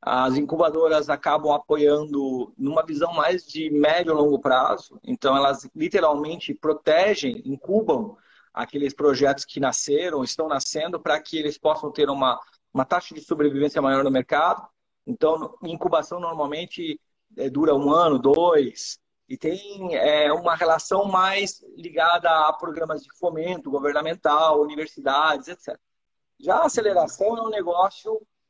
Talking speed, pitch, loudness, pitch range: 135 wpm, 155 Hz, -22 LUFS, 145-180 Hz